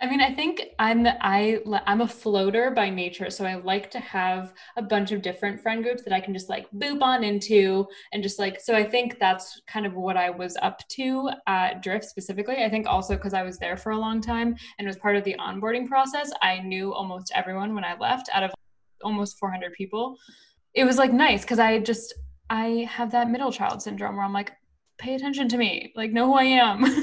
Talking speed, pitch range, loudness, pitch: 225 wpm, 195-245 Hz, -25 LUFS, 215 Hz